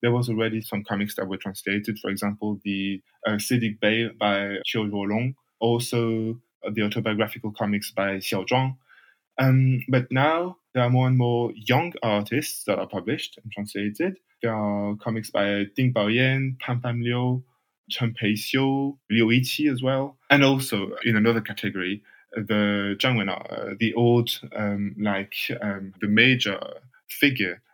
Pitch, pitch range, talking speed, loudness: 115 Hz, 105-125 Hz, 155 wpm, -24 LUFS